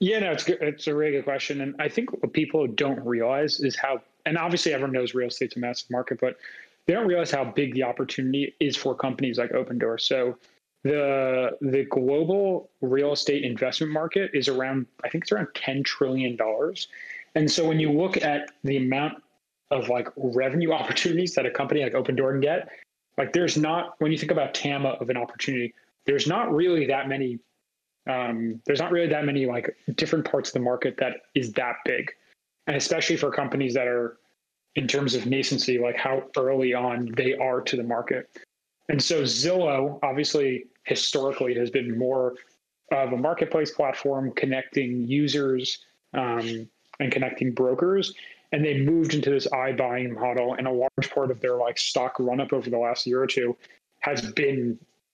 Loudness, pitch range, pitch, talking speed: -26 LUFS, 125-150 Hz, 135 Hz, 185 wpm